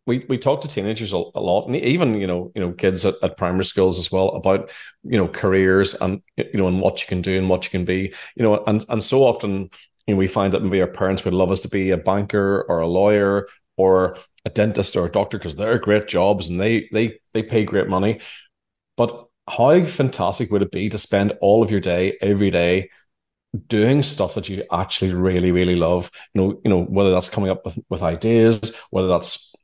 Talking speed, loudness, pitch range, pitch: 230 wpm, -20 LUFS, 95-110 Hz, 95 Hz